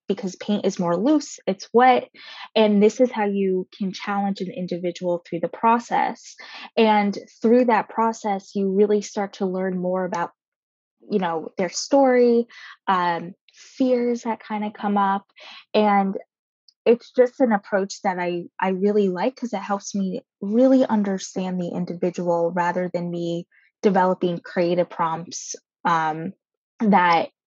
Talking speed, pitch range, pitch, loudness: 145 wpm, 180-220 Hz, 200 Hz, -22 LUFS